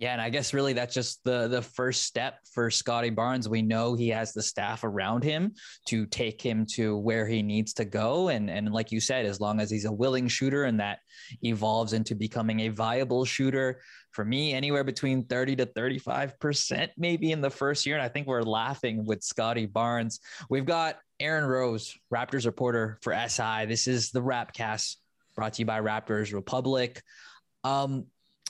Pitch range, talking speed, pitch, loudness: 110-130 Hz, 190 wpm, 120 Hz, -29 LUFS